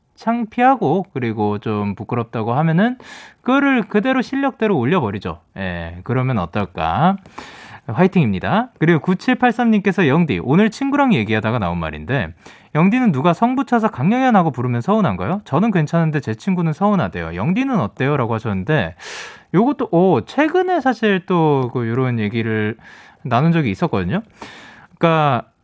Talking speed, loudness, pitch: 340 characters per minute, -18 LUFS, 170 Hz